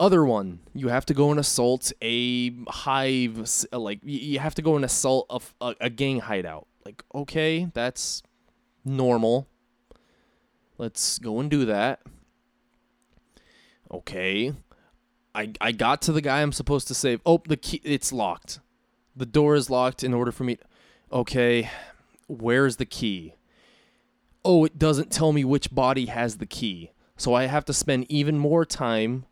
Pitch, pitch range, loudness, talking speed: 130 Hz, 120-145 Hz, -24 LUFS, 160 wpm